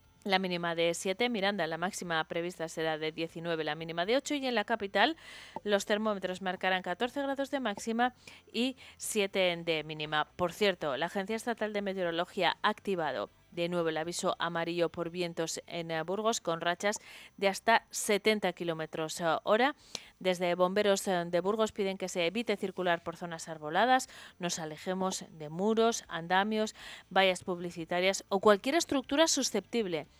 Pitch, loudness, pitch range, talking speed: 185 Hz, -32 LUFS, 170-210 Hz, 155 wpm